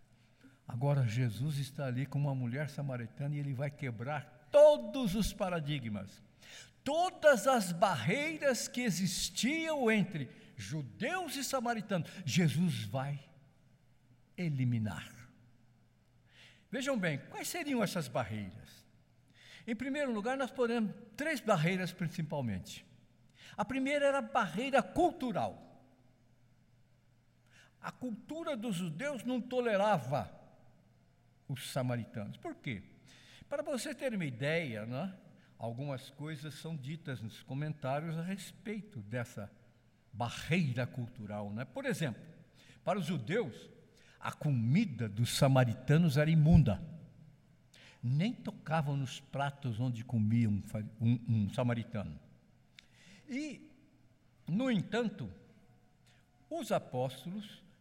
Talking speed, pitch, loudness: 105 wpm, 150 Hz, -35 LUFS